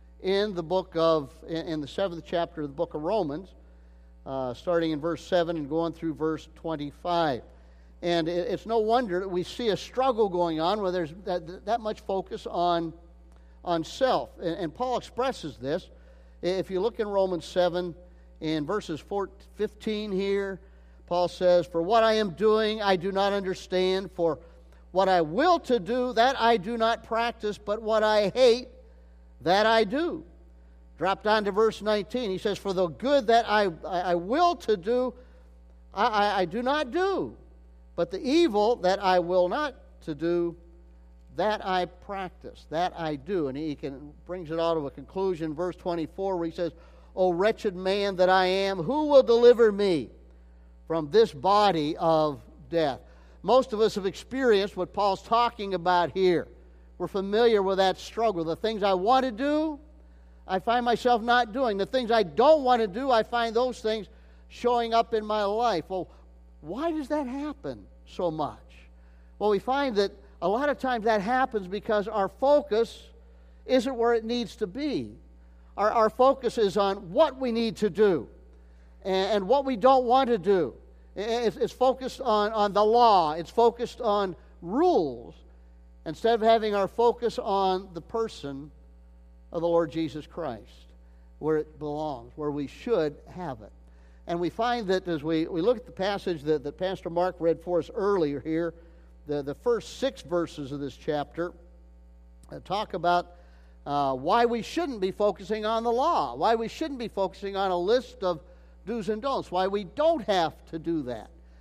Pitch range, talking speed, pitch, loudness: 155-225 Hz, 180 wpm, 185 Hz, -27 LUFS